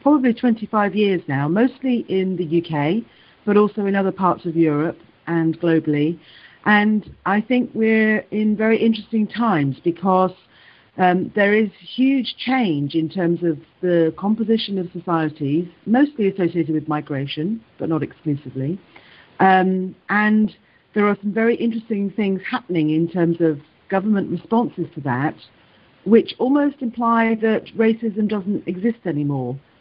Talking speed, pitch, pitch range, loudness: 140 wpm, 190 Hz, 165-220 Hz, -20 LUFS